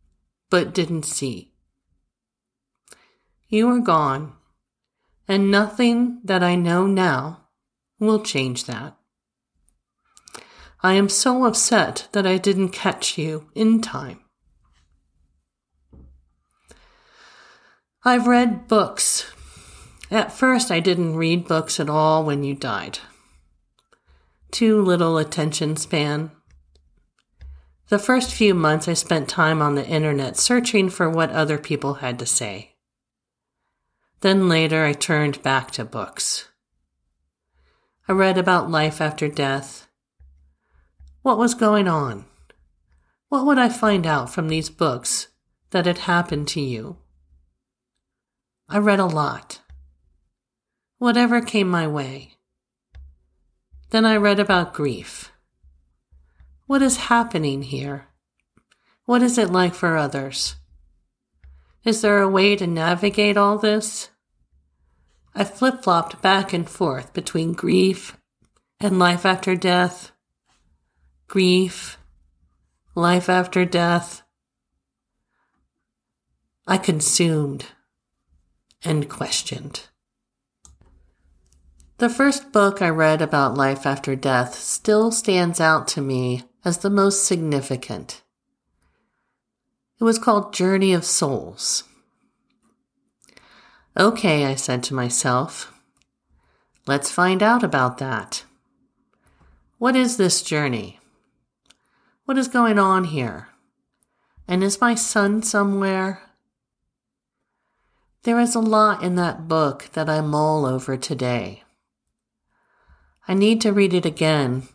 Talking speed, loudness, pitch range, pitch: 110 wpm, -20 LUFS, 120-195 Hz, 160 Hz